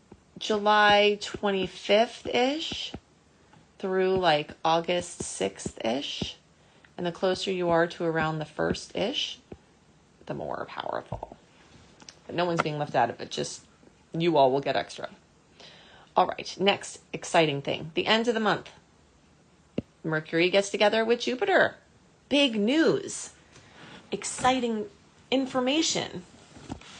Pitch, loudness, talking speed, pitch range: 190 Hz, -27 LUFS, 120 wpm, 165-220 Hz